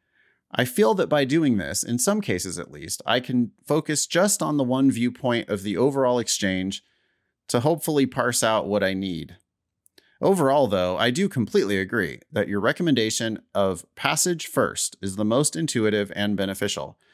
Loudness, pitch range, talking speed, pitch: -23 LUFS, 100-135 Hz, 170 wpm, 115 Hz